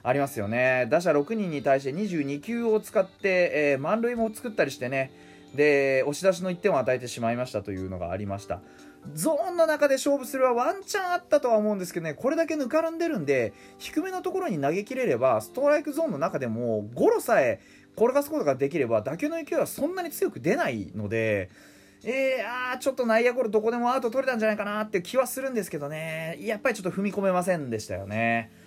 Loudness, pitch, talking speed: -26 LUFS, 205 Hz, 455 characters per minute